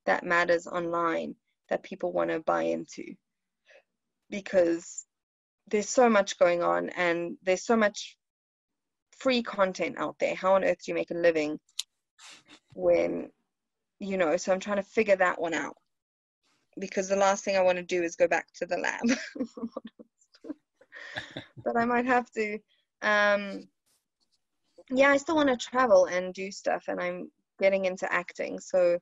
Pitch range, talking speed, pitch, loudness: 175-235 Hz, 160 wpm, 195 Hz, -27 LUFS